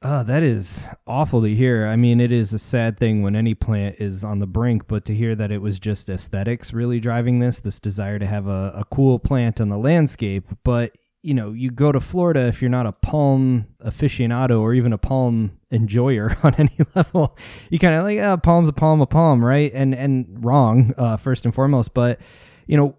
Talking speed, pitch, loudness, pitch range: 220 wpm, 120 Hz, -19 LUFS, 110-135 Hz